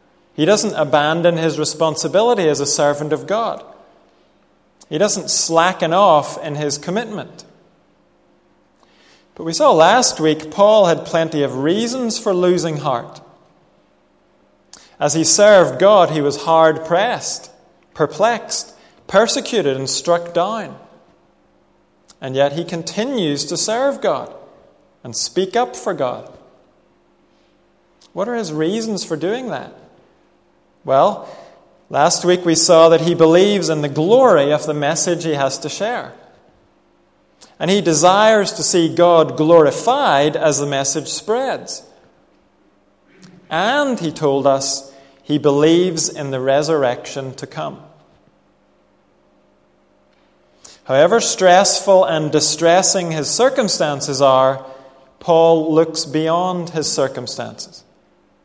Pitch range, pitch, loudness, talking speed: 145-185 Hz, 160 Hz, -15 LUFS, 115 wpm